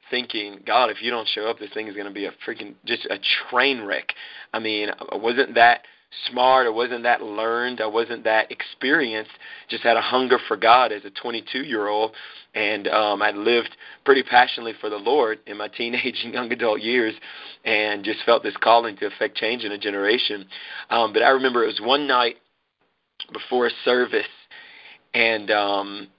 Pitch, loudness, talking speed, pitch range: 115 Hz, -21 LUFS, 190 wpm, 105-125 Hz